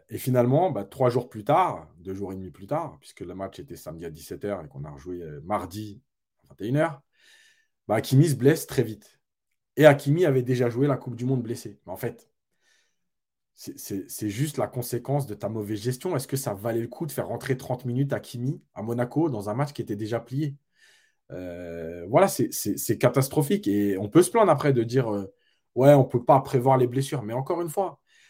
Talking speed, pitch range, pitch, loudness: 225 wpm, 105-145 Hz, 125 Hz, -25 LUFS